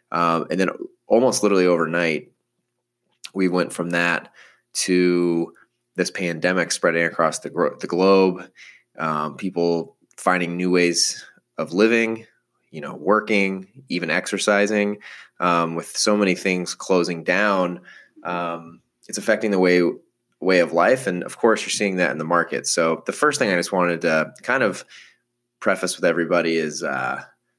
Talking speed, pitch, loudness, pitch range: 150 wpm, 90 Hz, -21 LUFS, 85-100 Hz